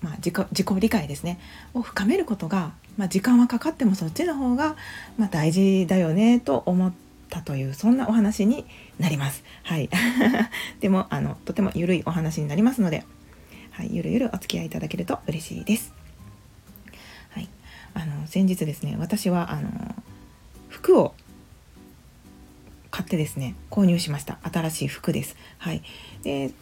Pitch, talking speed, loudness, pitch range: 185 Hz, 305 characters per minute, -24 LUFS, 155-215 Hz